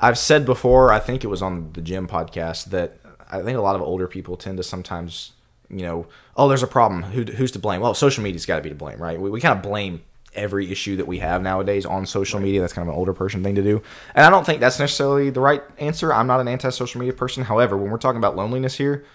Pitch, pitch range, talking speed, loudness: 105 Hz, 95-130 Hz, 270 wpm, -20 LUFS